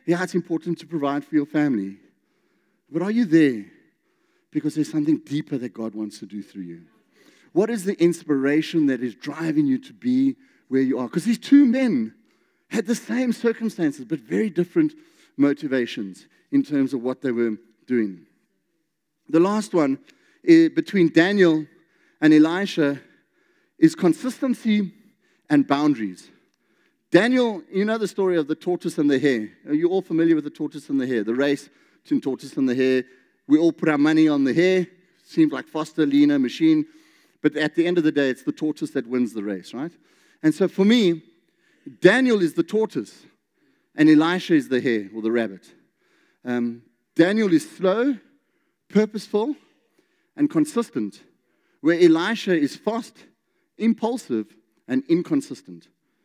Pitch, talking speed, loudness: 175 Hz, 160 wpm, -22 LUFS